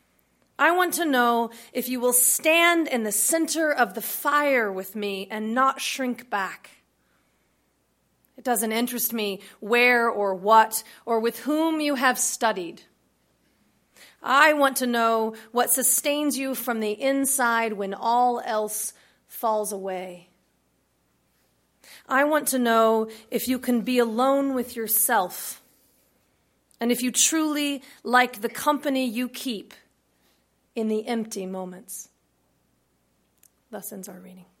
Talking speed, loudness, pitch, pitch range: 130 wpm, -23 LUFS, 235 Hz, 200-255 Hz